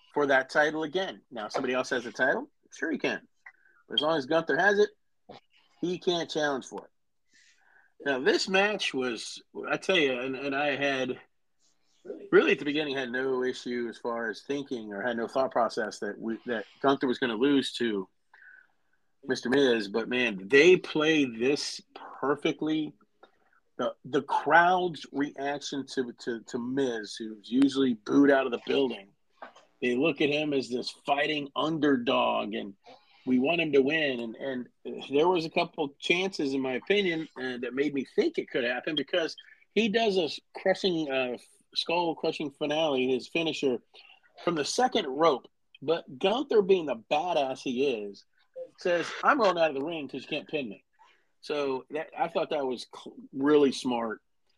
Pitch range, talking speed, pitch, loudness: 125-160 Hz, 175 wpm, 140 Hz, -28 LUFS